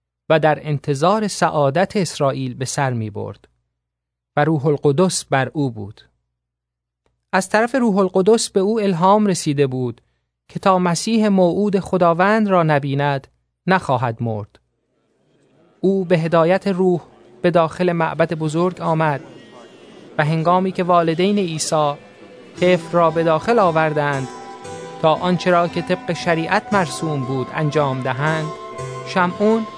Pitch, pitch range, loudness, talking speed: 160 Hz, 135-185 Hz, -18 LUFS, 125 wpm